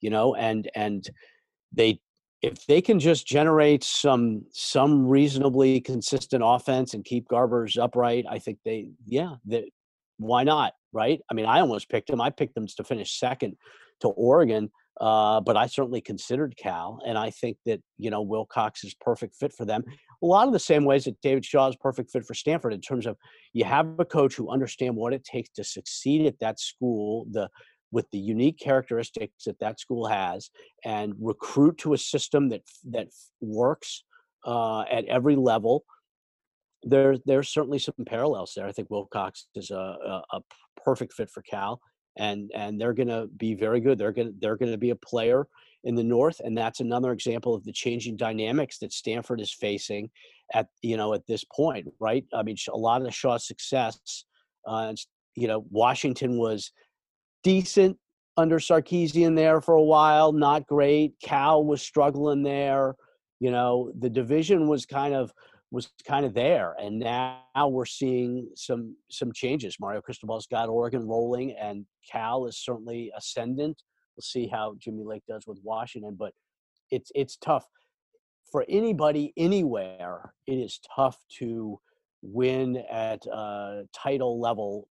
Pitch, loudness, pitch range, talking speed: 125 Hz, -26 LUFS, 110-145 Hz, 170 wpm